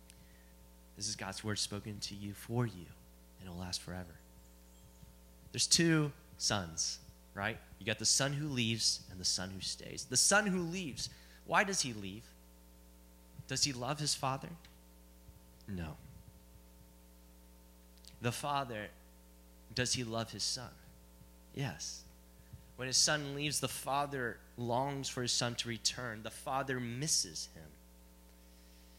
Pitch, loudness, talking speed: 90 Hz, -35 LUFS, 140 wpm